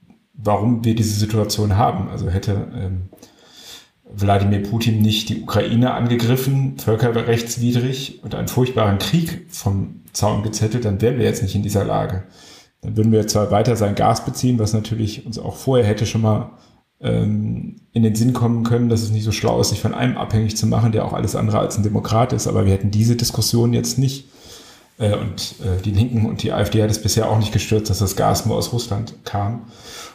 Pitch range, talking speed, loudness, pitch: 105-120 Hz, 200 wpm, -19 LUFS, 110 Hz